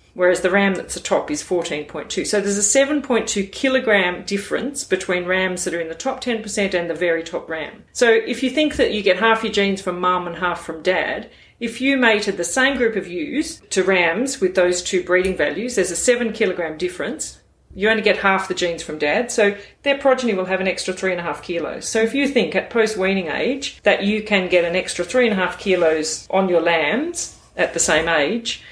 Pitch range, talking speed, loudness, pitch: 180-230 Hz, 215 wpm, -19 LUFS, 195 Hz